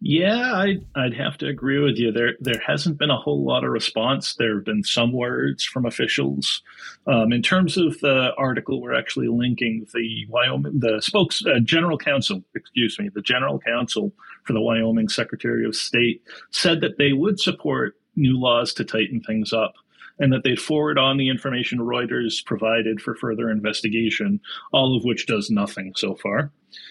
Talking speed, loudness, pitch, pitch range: 180 wpm, -22 LUFS, 120 Hz, 110-140 Hz